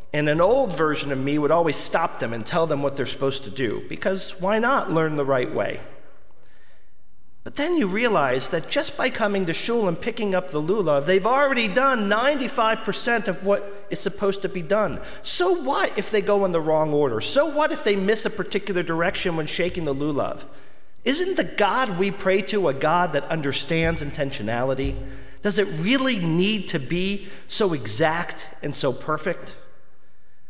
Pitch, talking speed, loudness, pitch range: 185 Hz, 185 wpm, -23 LUFS, 150-215 Hz